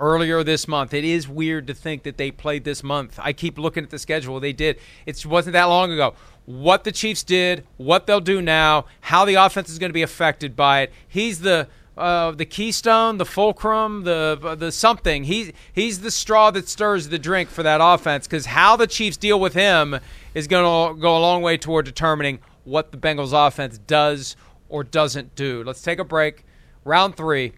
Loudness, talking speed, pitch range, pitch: -19 LUFS, 205 wpm, 150-185 Hz, 160 Hz